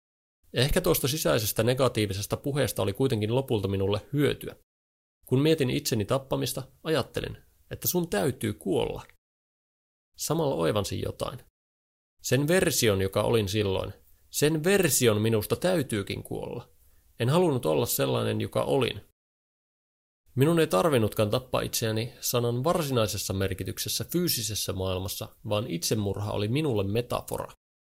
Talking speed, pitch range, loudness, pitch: 115 wpm, 95-135 Hz, -27 LUFS, 110 Hz